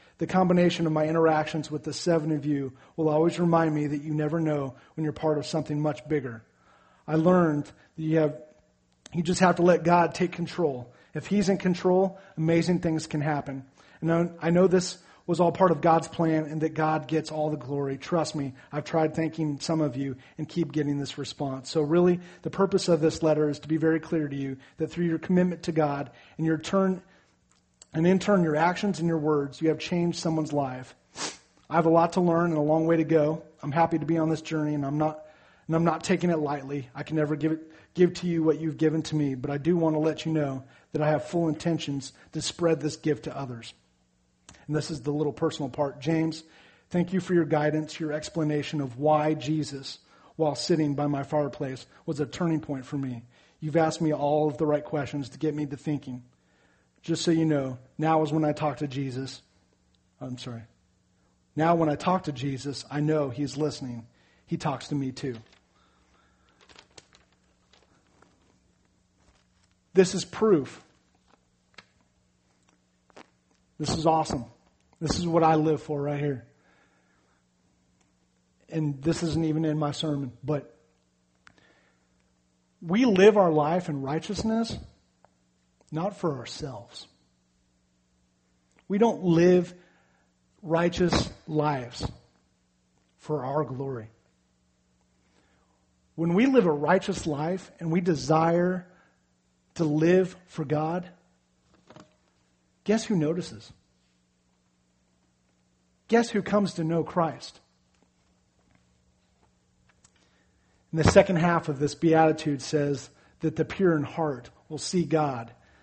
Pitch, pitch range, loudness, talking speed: 150 Hz, 130-165 Hz, -27 LUFS, 165 wpm